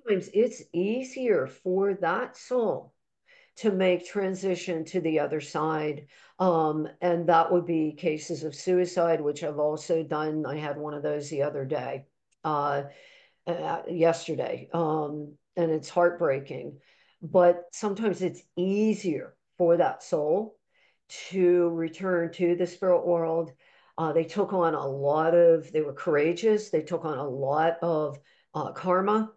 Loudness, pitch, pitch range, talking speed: -27 LUFS, 170 Hz, 155-185 Hz, 145 wpm